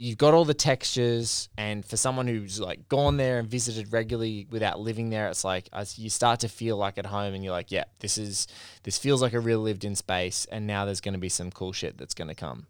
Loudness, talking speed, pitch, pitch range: -28 LUFS, 260 wpm, 110 Hz, 100-120 Hz